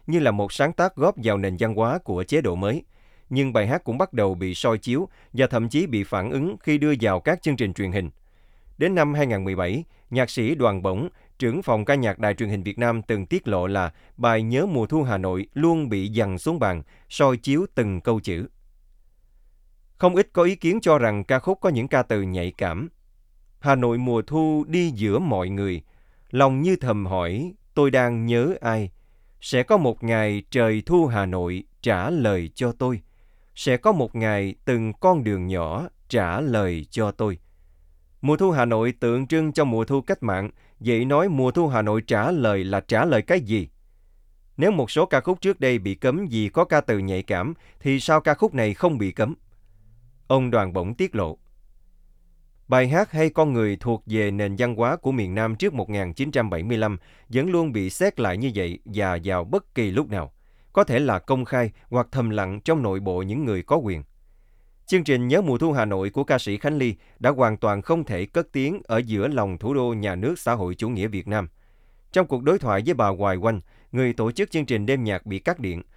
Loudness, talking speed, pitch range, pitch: -23 LUFS, 215 wpm, 100-140 Hz, 115 Hz